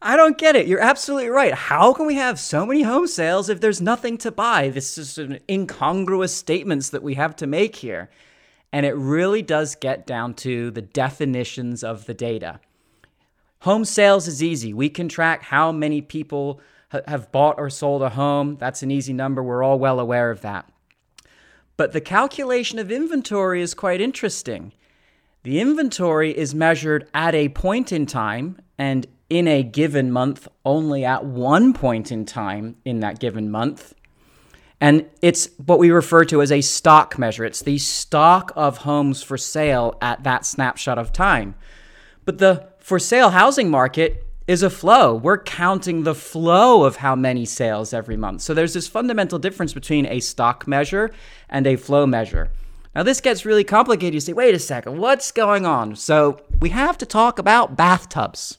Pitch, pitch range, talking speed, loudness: 150 Hz, 130-190 Hz, 180 wpm, -19 LUFS